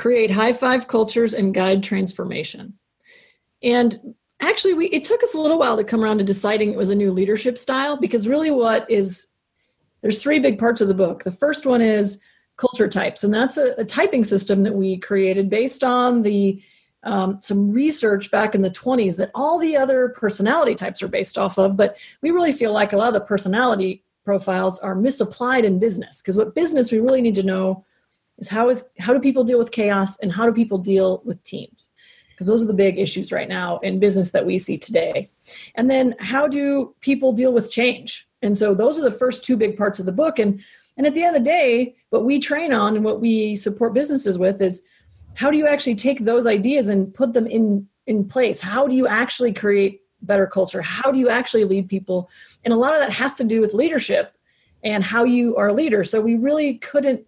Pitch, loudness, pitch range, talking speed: 225 Hz, -19 LUFS, 200-255 Hz, 220 wpm